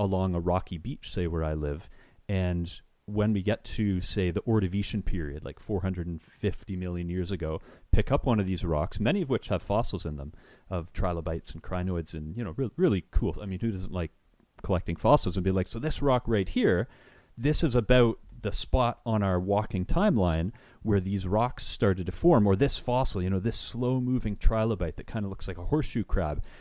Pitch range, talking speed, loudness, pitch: 90-110 Hz, 205 wpm, -29 LUFS, 95 Hz